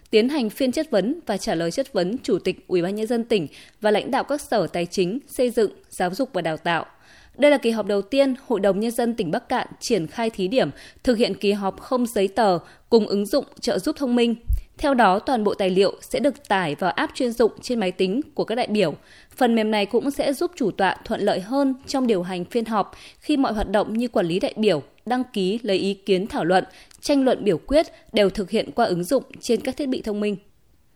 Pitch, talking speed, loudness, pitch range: 220 Hz, 250 wpm, -23 LUFS, 195-260 Hz